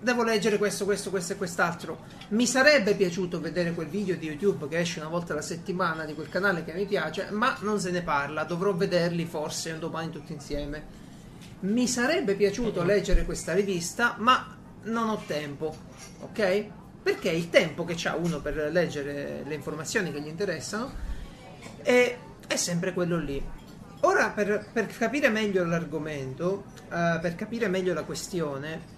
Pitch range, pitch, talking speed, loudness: 160-205 Hz, 180 Hz, 165 wpm, -28 LUFS